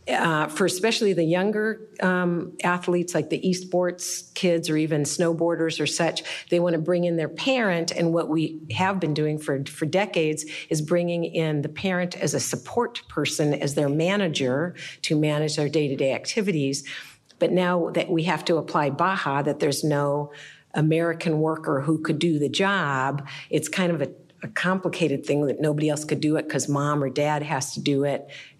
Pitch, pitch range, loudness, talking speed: 160 Hz, 150-175 Hz, -24 LUFS, 185 wpm